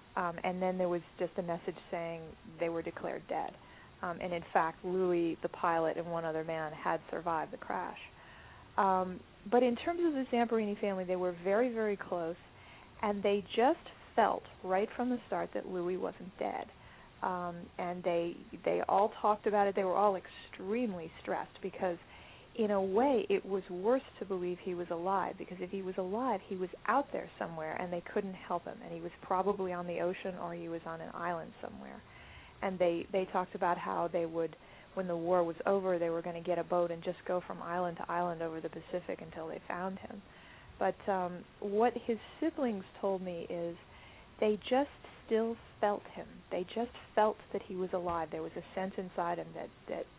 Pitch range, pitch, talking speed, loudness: 175-205 Hz, 185 Hz, 200 wpm, -35 LUFS